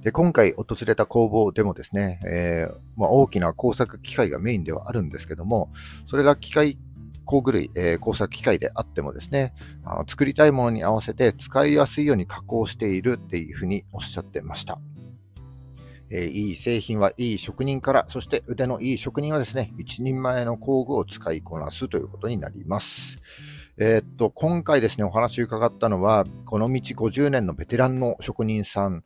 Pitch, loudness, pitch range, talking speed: 110 Hz, -24 LUFS, 95-130 Hz, 375 characters per minute